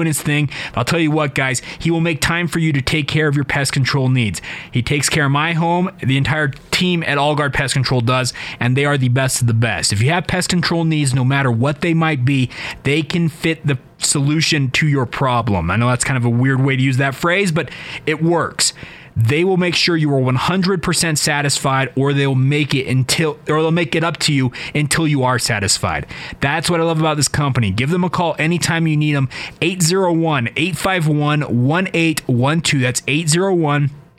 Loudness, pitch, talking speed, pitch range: -16 LUFS, 145 Hz, 215 wpm, 135-165 Hz